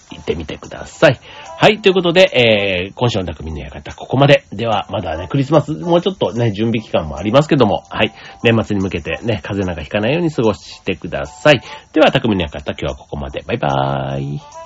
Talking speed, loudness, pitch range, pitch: 425 characters per minute, -16 LUFS, 90-145 Hz, 110 Hz